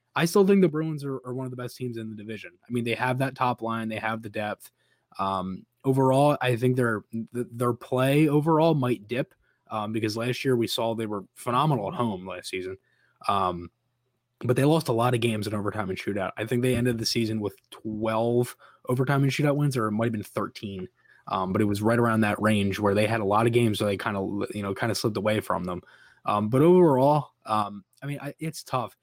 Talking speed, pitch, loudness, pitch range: 240 wpm, 115 Hz, -26 LUFS, 105-130 Hz